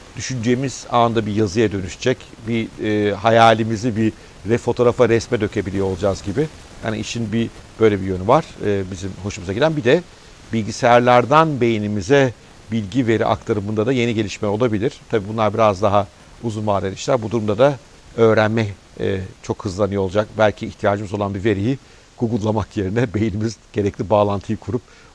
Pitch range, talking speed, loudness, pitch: 100-120 Hz, 155 wpm, -19 LUFS, 110 Hz